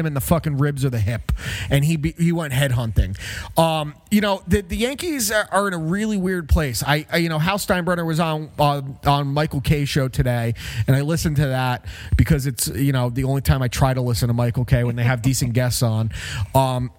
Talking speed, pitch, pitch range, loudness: 240 wpm, 140 Hz, 125-165 Hz, -21 LUFS